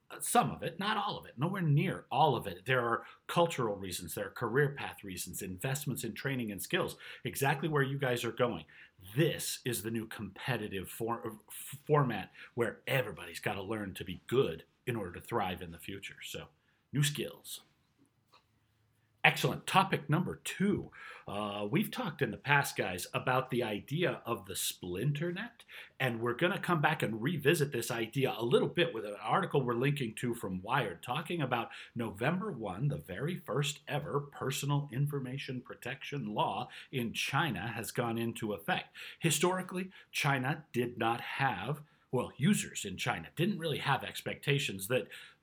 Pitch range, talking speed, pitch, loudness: 115-150 Hz, 170 wpm, 130 Hz, -34 LUFS